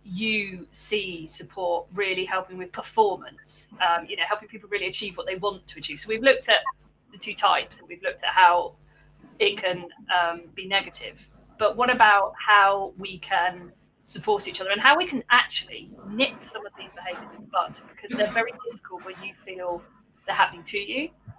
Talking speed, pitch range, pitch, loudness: 195 wpm, 185-245 Hz, 205 Hz, -24 LUFS